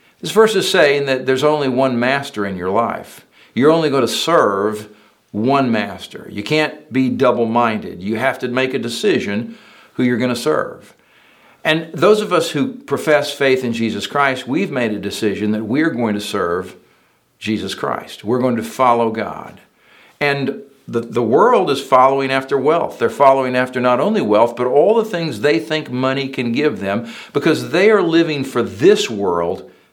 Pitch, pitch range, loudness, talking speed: 130 Hz, 115-145 Hz, -16 LUFS, 185 wpm